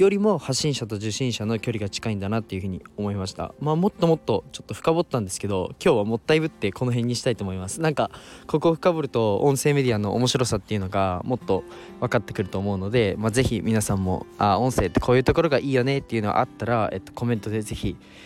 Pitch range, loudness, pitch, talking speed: 100-135 Hz, -24 LUFS, 115 Hz, 525 characters per minute